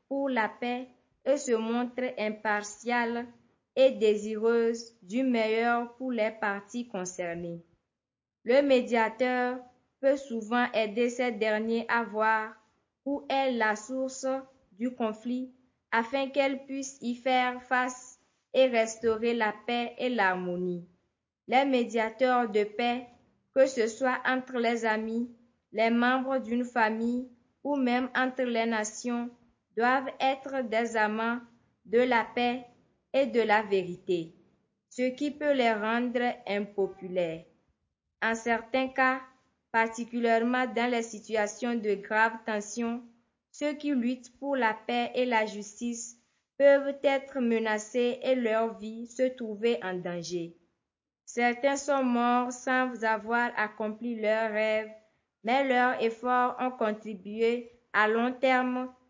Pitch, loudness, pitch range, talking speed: 235 Hz, -29 LUFS, 220-255 Hz, 125 wpm